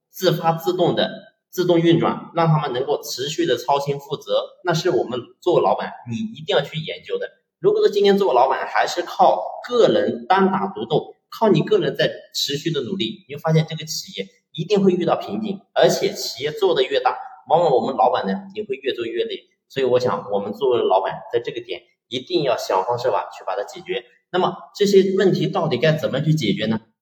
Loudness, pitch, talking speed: -20 LUFS, 195 Hz, 315 characters per minute